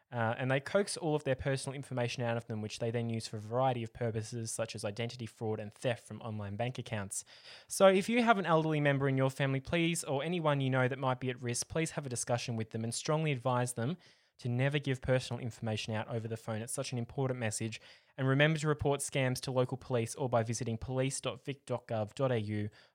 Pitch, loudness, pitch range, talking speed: 125 Hz, -34 LUFS, 115-140 Hz, 225 wpm